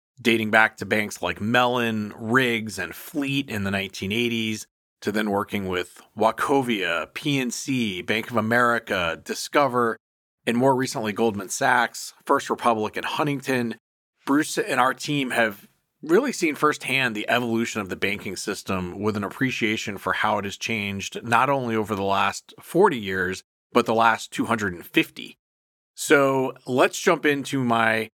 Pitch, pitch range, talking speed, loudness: 115 Hz, 100-125 Hz, 145 wpm, -23 LUFS